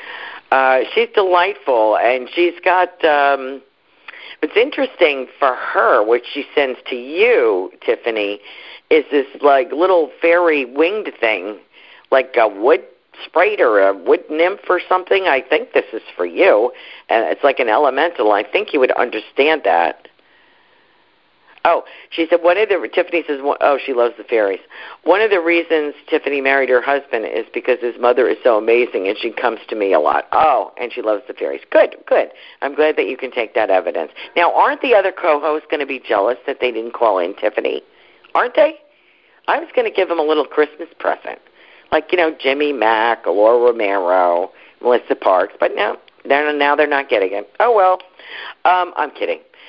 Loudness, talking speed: -16 LUFS, 180 wpm